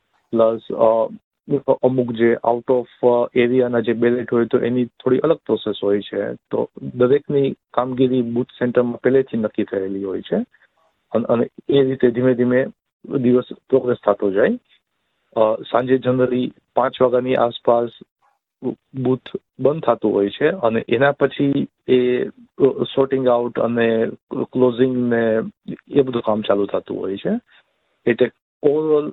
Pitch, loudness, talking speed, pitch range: 125 Hz, -19 LUFS, 130 wpm, 115-130 Hz